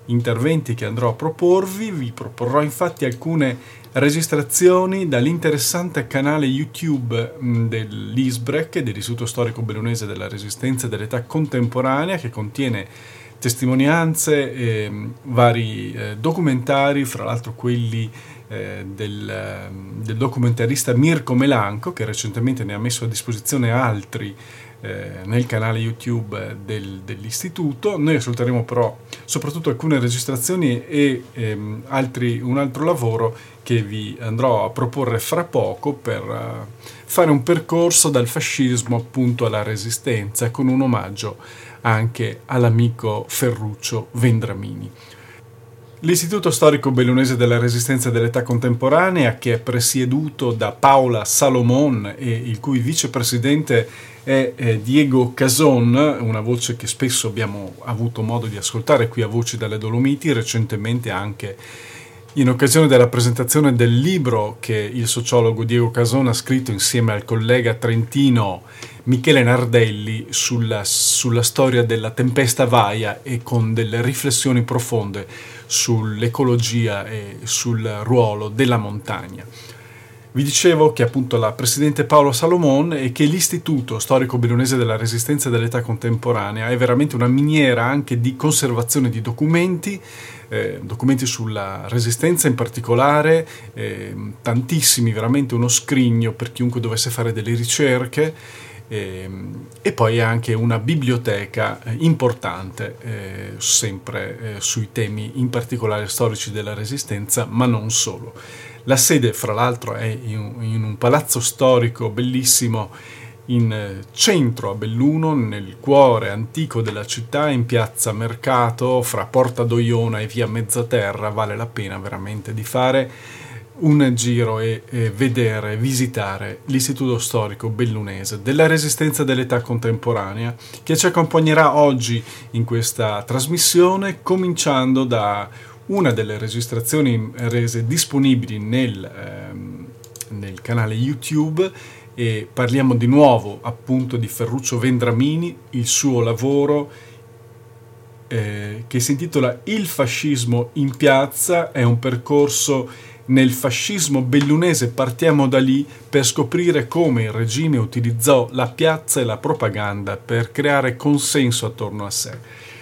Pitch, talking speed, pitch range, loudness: 120 Hz, 125 wpm, 115-135 Hz, -18 LUFS